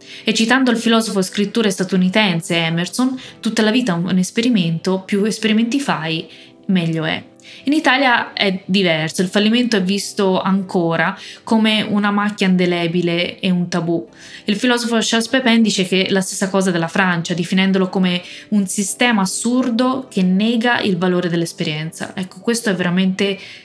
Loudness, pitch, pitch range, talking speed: -17 LUFS, 195 Hz, 180-225 Hz, 150 wpm